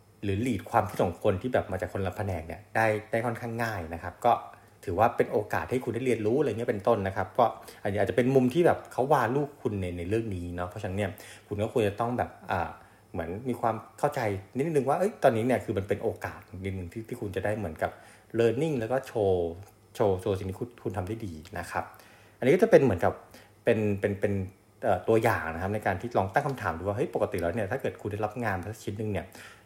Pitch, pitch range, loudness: 105 Hz, 95-120 Hz, -29 LUFS